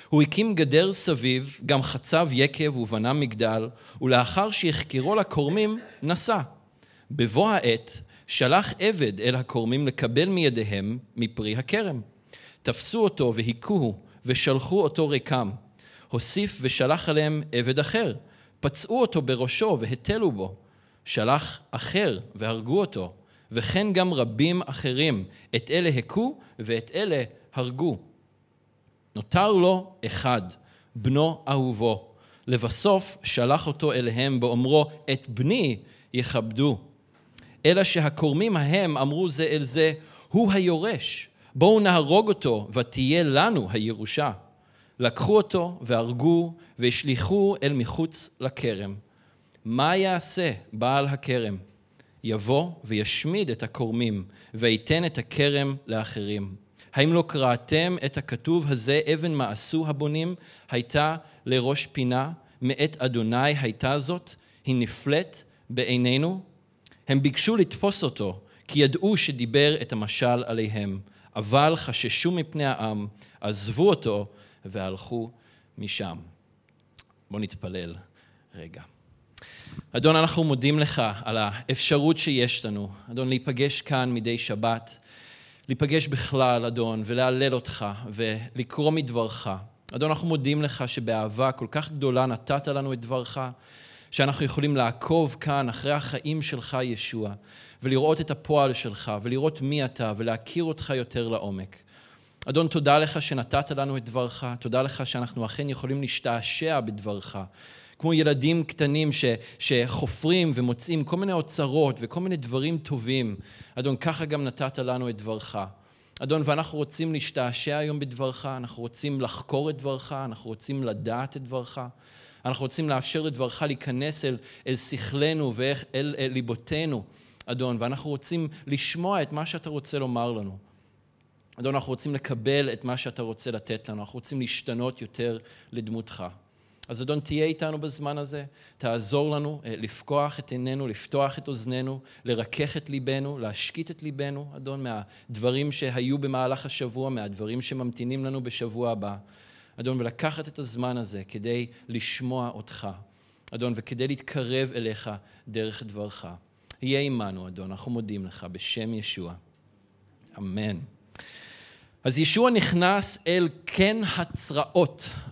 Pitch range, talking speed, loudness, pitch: 115-150 Hz, 120 wpm, -26 LUFS, 130 Hz